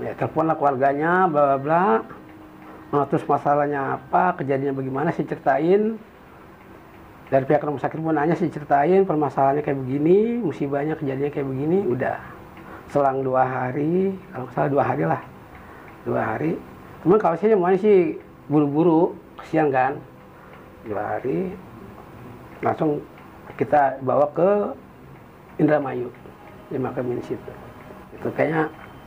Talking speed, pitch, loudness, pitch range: 120 wpm, 145 Hz, -22 LUFS, 140-170 Hz